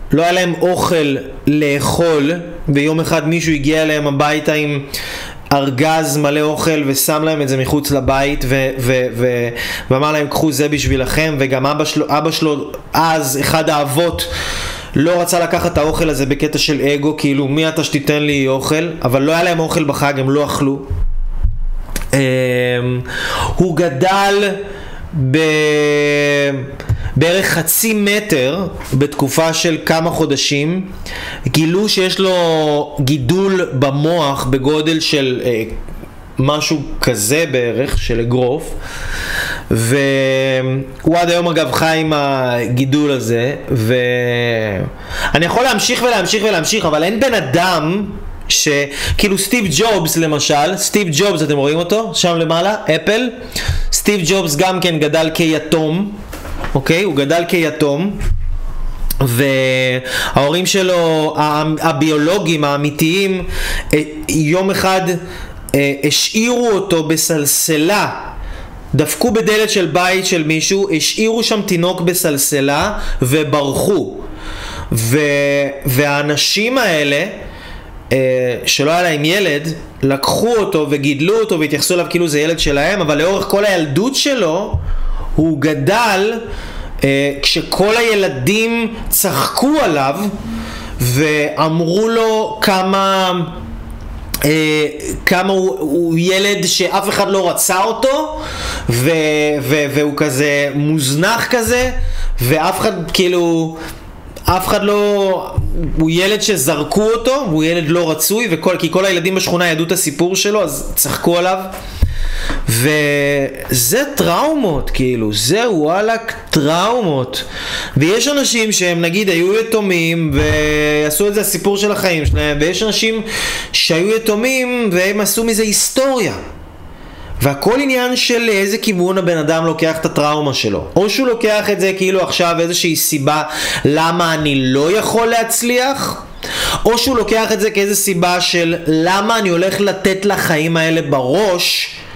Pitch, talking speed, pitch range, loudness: 160 Hz, 120 wpm, 140-190 Hz, -14 LUFS